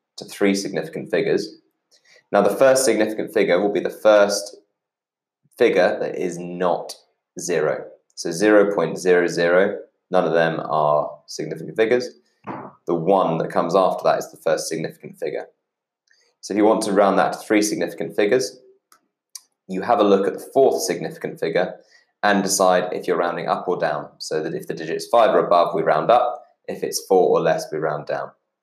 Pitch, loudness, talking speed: 105 Hz, -20 LUFS, 180 wpm